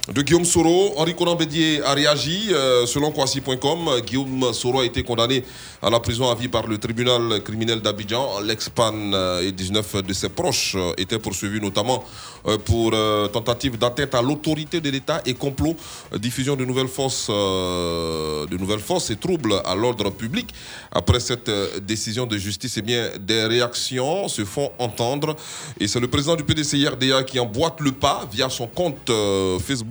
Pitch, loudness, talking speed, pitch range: 120 Hz, -21 LUFS, 160 wpm, 105-140 Hz